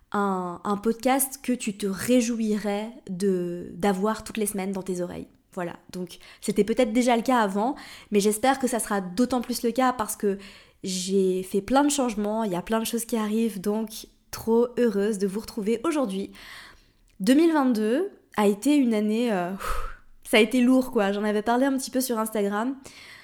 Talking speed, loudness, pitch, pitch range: 190 wpm, -25 LUFS, 220 Hz, 200-250 Hz